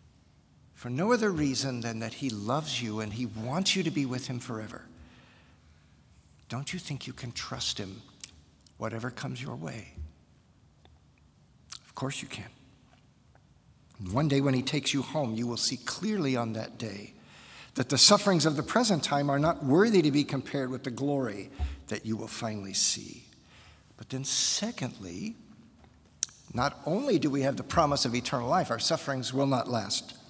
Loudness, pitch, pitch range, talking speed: -28 LUFS, 130 Hz, 110-145 Hz, 170 wpm